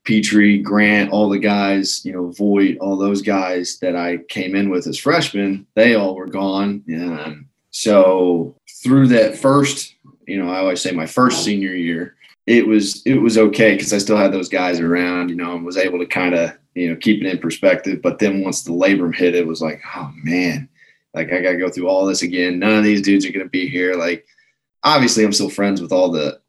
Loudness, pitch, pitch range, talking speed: -17 LUFS, 95 Hz, 90-105 Hz, 220 wpm